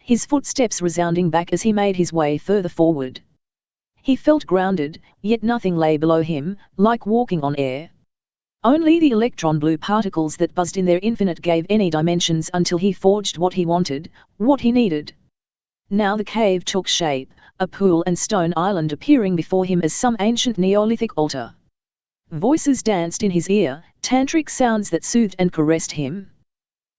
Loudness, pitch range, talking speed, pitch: -19 LUFS, 165-220 Hz, 165 wpm, 185 Hz